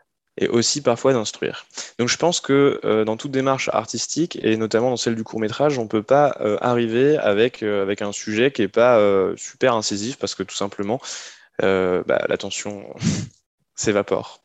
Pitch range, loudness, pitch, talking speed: 105-135 Hz, -20 LUFS, 115 Hz, 185 wpm